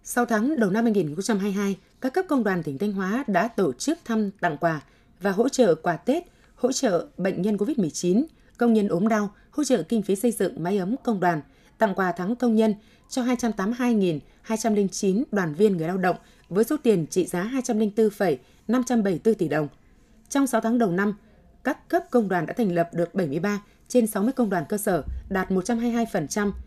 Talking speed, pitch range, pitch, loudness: 190 wpm, 185-235 Hz, 210 Hz, -24 LUFS